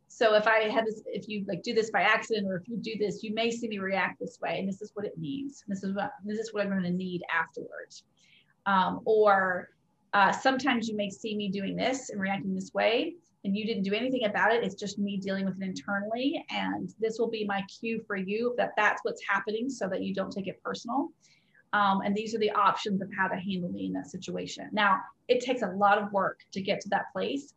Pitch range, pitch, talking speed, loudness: 195-225 Hz, 205 Hz, 250 wpm, -29 LUFS